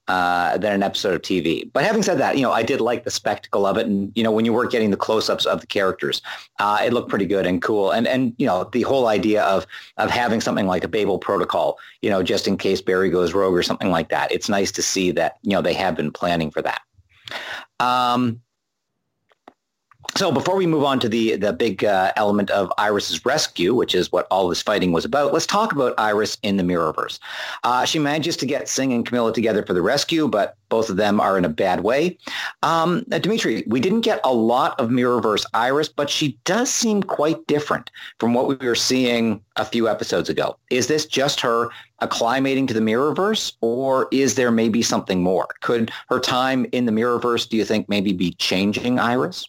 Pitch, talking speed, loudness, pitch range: 120 Hz, 220 wpm, -20 LUFS, 110-140 Hz